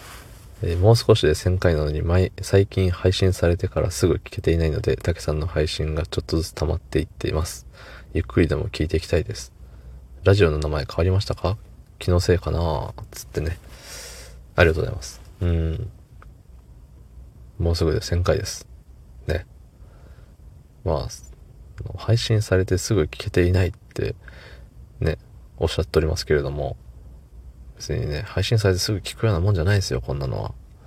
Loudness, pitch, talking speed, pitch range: -23 LUFS, 85 Hz, 335 characters per minute, 75-95 Hz